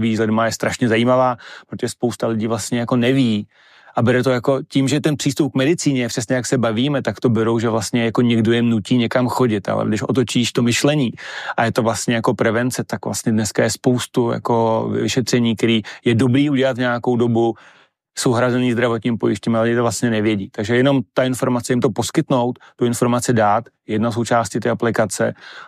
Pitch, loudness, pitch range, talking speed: 120 Hz, -18 LUFS, 115-130 Hz, 195 wpm